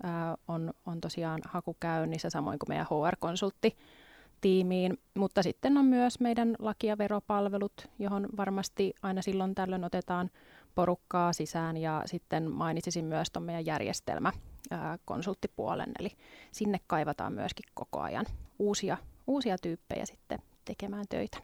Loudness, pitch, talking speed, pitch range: -33 LUFS, 185 Hz, 125 wpm, 170-205 Hz